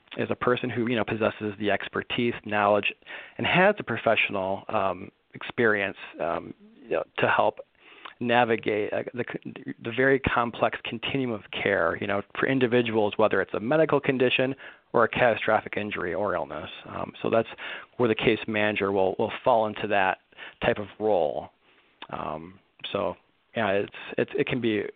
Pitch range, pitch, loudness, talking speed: 105-125 Hz, 115 Hz, -26 LUFS, 160 wpm